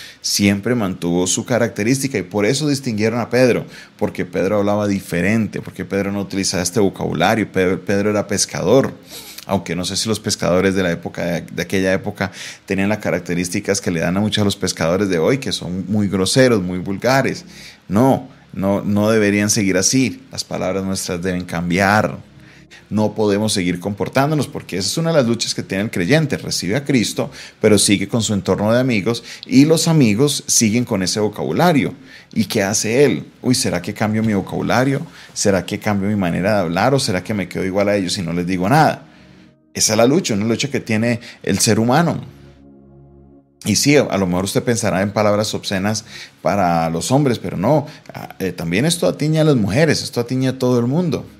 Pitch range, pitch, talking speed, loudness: 95-115 Hz, 100 Hz, 195 wpm, -17 LUFS